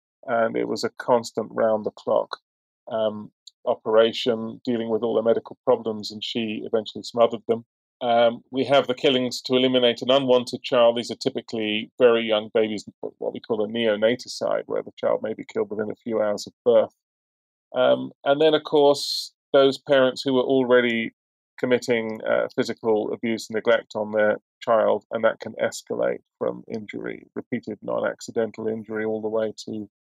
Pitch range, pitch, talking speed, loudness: 110-125 Hz, 115 Hz, 175 wpm, -23 LUFS